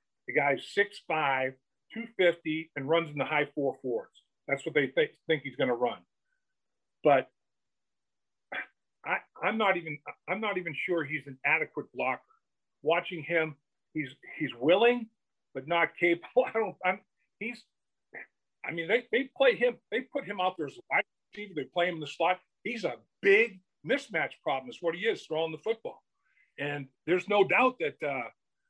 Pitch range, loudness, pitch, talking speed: 160-240 Hz, -30 LUFS, 185 Hz, 170 wpm